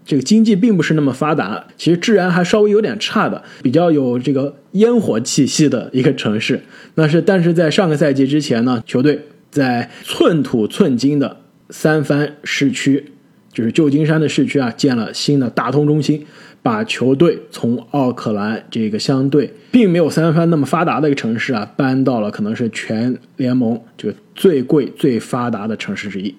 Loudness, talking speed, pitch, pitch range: -16 LUFS, 280 characters per minute, 150 Hz, 130-170 Hz